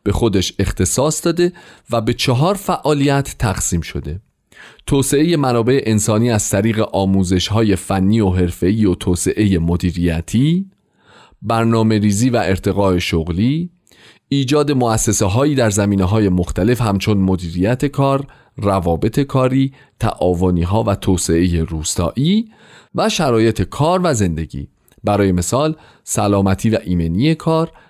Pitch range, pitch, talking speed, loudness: 95-135 Hz, 110 Hz, 120 wpm, -16 LUFS